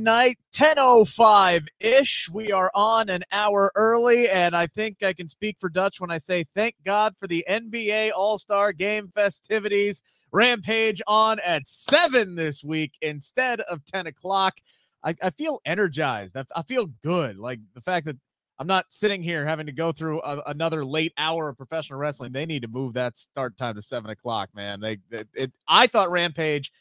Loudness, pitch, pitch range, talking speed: -23 LUFS, 180 Hz, 150-215 Hz, 180 wpm